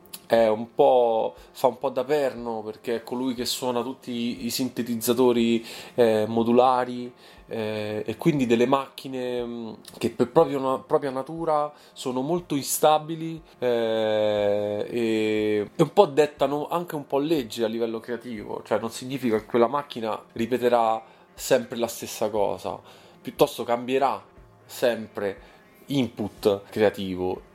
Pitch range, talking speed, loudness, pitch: 115-140 Hz, 130 wpm, -25 LUFS, 125 Hz